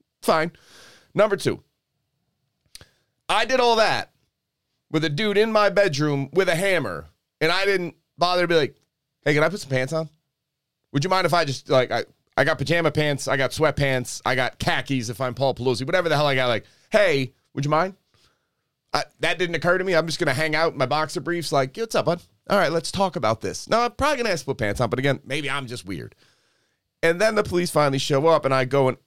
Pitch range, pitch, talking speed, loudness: 135-175 Hz, 155 Hz, 240 wpm, -22 LUFS